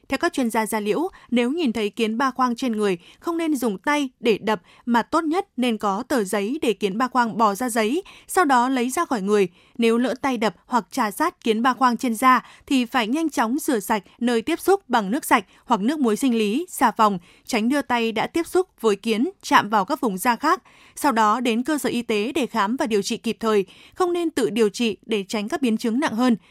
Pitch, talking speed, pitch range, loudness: 245 Hz, 250 wpm, 220-275 Hz, -22 LUFS